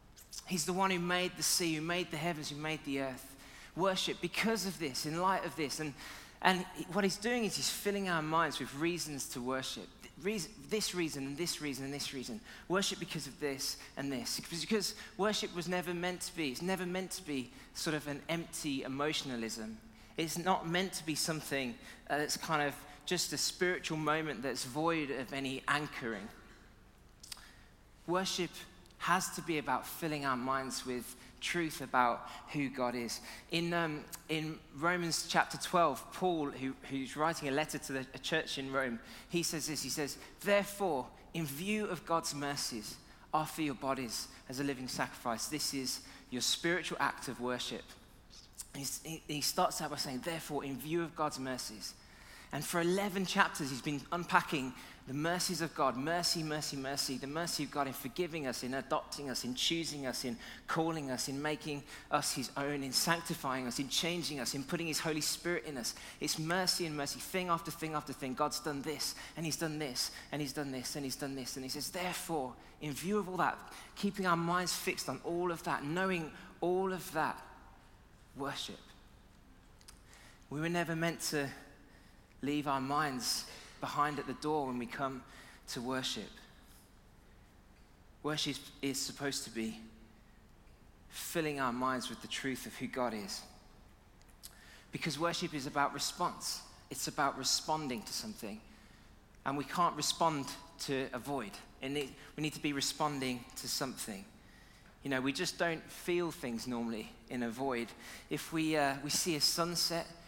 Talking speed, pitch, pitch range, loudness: 175 wpm, 150 Hz, 135-170 Hz, -36 LUFS